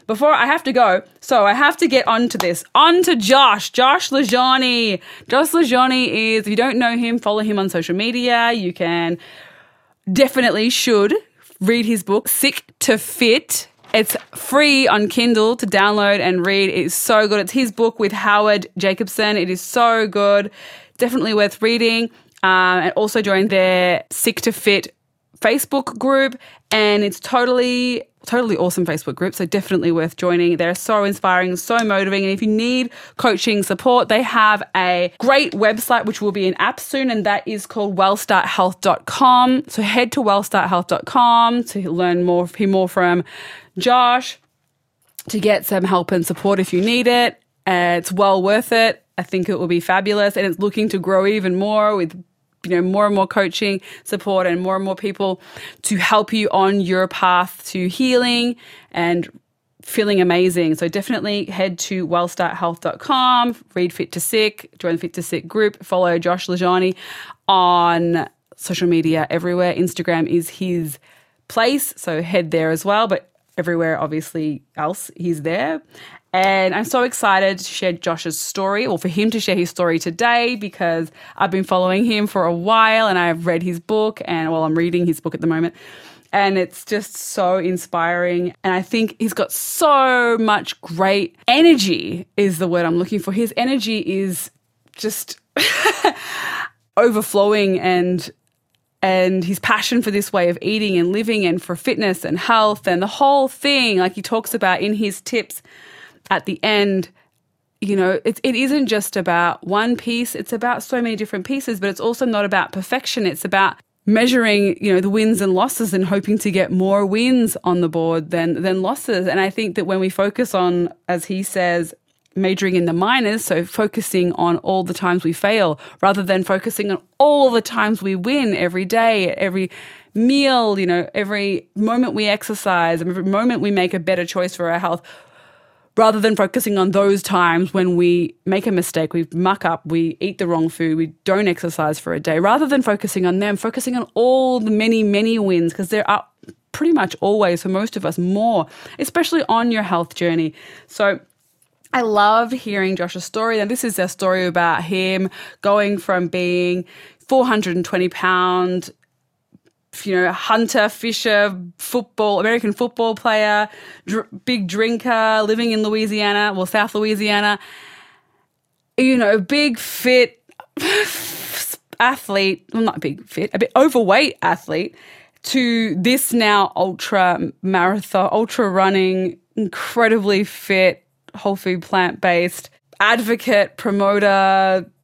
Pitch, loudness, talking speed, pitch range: 200 Hz, -17 LUFS, 170 wpm, 180-225 Hz